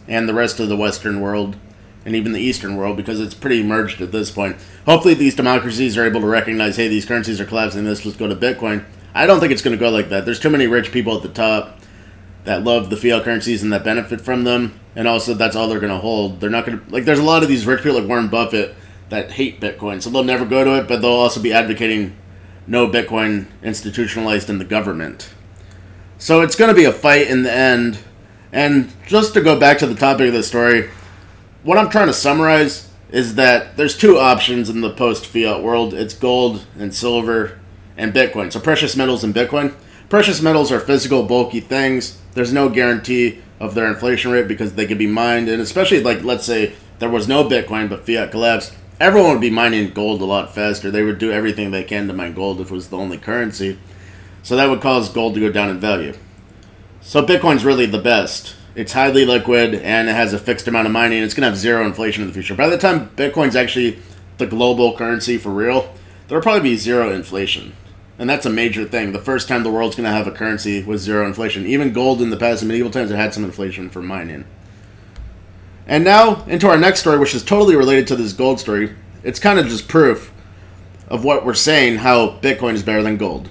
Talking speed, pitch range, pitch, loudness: 225 wpm, 100-125 Hz, 110 Hz, -16 LUFS